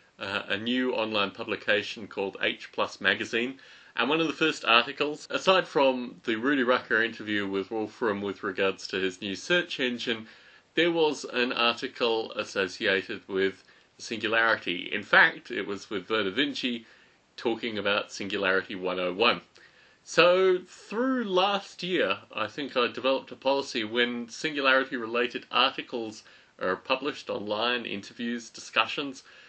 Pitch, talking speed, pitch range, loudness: 120 Hz, 135 wpm, 110-145 Hz, -27 LUFS